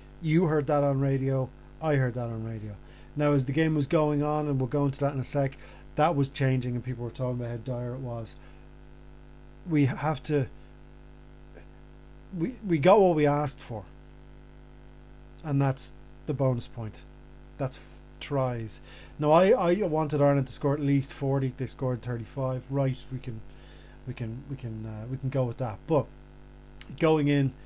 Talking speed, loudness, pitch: 180 wpm, -28 LUFS, 130 Hz